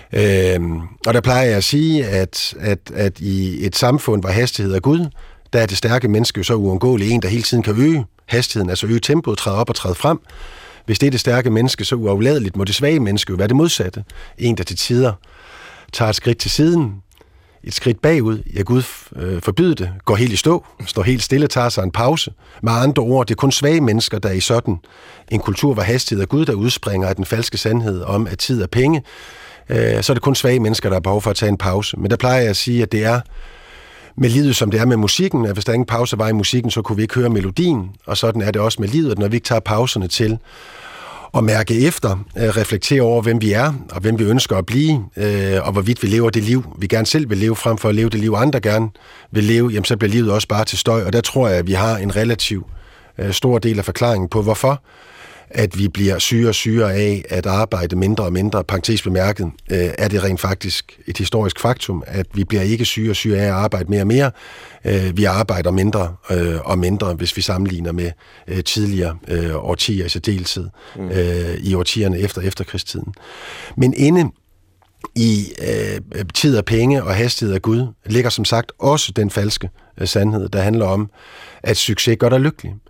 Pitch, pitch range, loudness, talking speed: 110 Hz, 95-120 Hz, -17 LUFS, 225 wpm